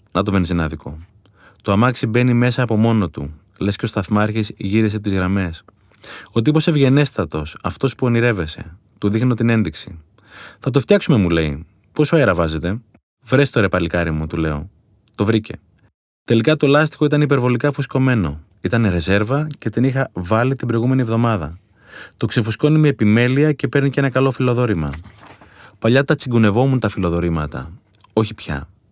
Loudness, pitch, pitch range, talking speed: -18 LUFS, 110 Hz, 95-130 Hz, 160 wpm